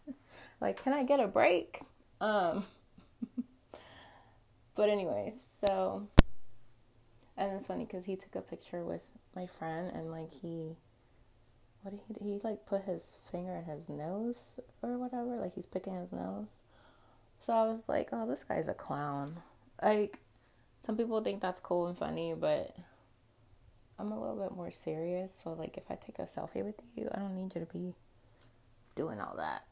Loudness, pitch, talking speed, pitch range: -36 LUFS, 175 Hz, 170 wpm, 120-200 Hz